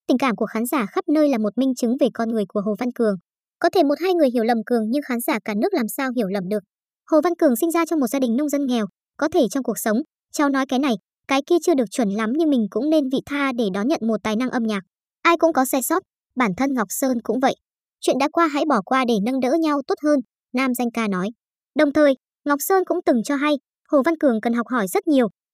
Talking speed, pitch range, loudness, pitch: 280 wpm, 230-300 Hz, -21 LUFS, 265 Hz